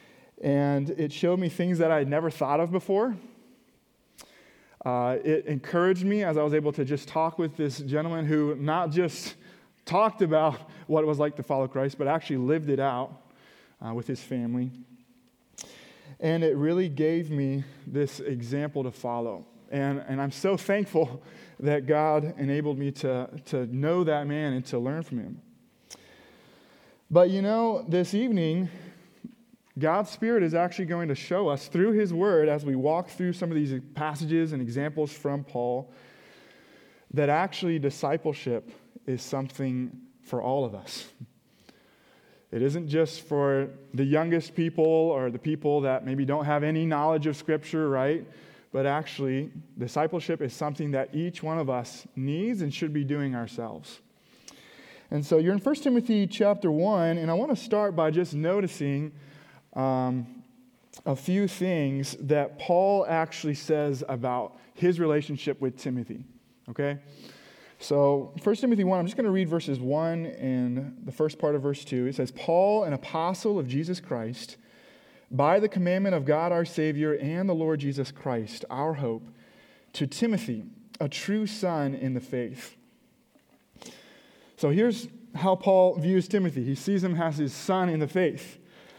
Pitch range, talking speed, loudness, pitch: 135-175 Hz, 160 wpm, -27 LUFS, 150 Hz